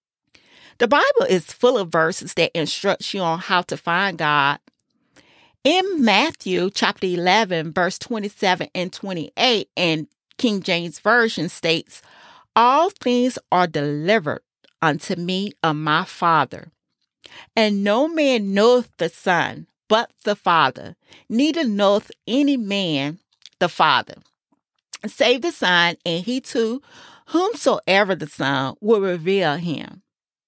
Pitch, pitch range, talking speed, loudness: 195 Hz, 170-230 Hz, 125 wpm, -20 LUFS